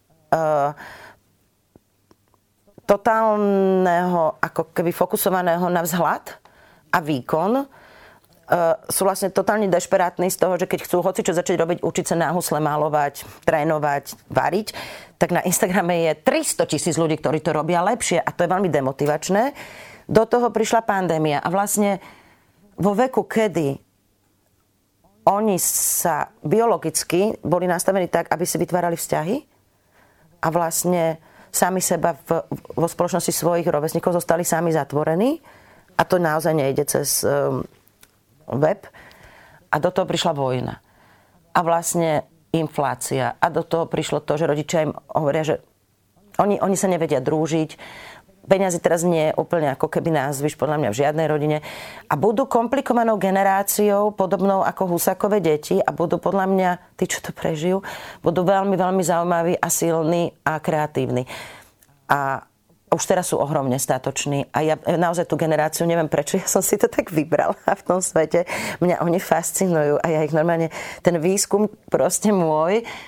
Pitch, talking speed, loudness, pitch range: 170 Hz, 145 wpm, -21 LUFS, 155-190 Hz